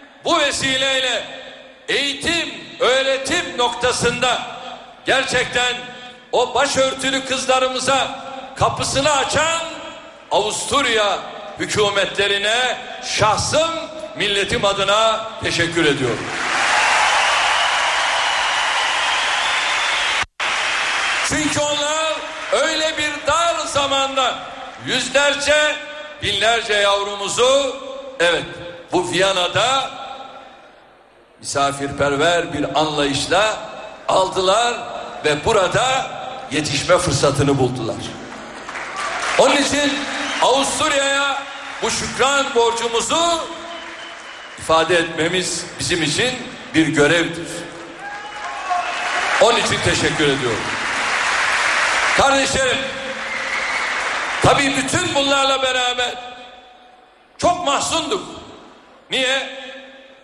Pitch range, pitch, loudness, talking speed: 200-290 Hz, 265 Hz, -17 LUFS, 65 wpm